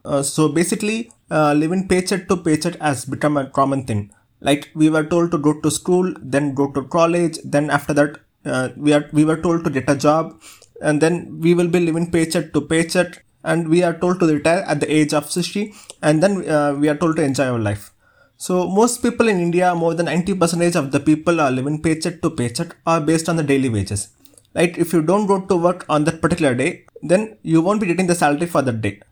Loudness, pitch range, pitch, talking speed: -18 LUFS, 145-175 Hz, 160 Hz, 230 wpm